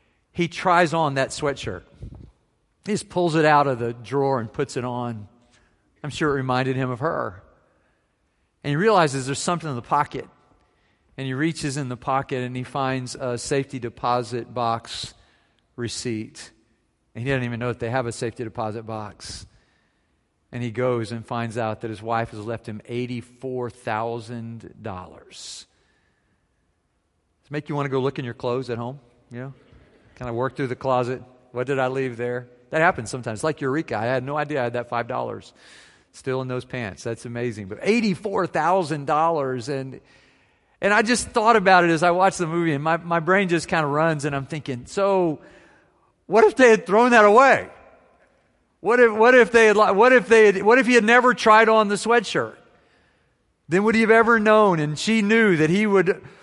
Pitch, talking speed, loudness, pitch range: 135 Hz, 190 wpm, -21 LUFS, 120-175 Hz